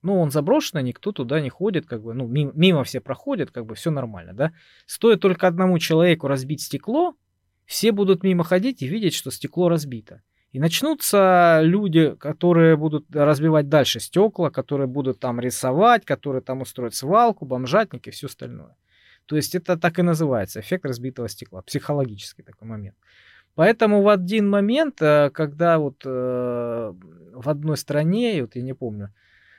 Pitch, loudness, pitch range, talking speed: 150 Hz, -21 LUFS, 130-180 Hz, 160 wpm